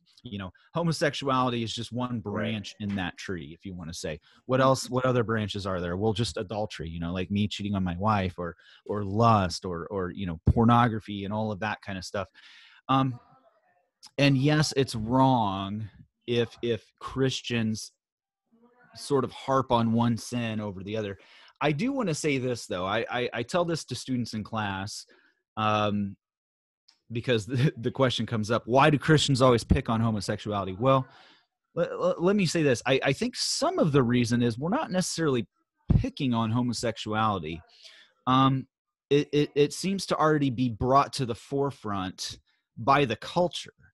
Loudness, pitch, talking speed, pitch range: -27 LUFS, 120 Hz, 175 wpm, 105-140 Hz